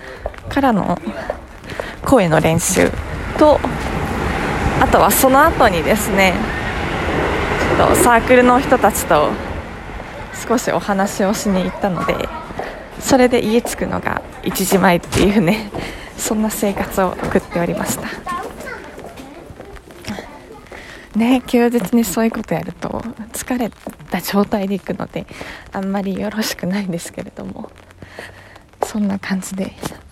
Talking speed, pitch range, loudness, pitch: 230 characters per minute, 185-235 Hz, -17 LUFS, 205 Hz